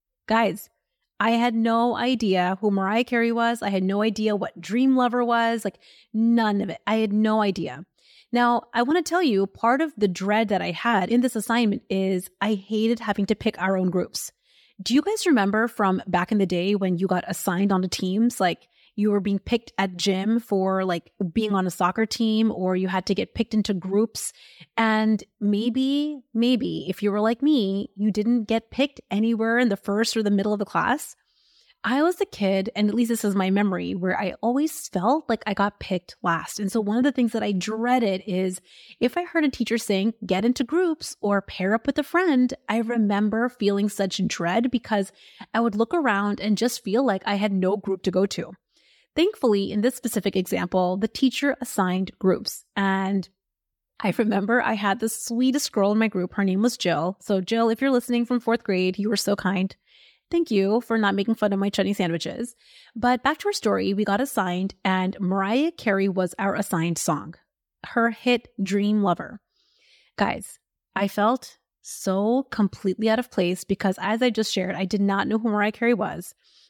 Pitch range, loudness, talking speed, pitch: 195-235 Hz, -24 LUFS, 205 wpm, 210 Hz